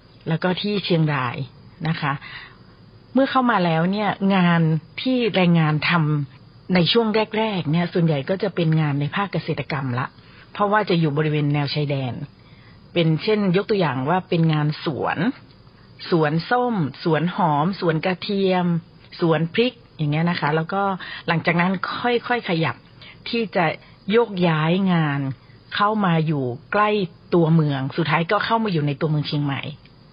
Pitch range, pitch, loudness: 150-195 Hz, 170 Hz, -21 LUFS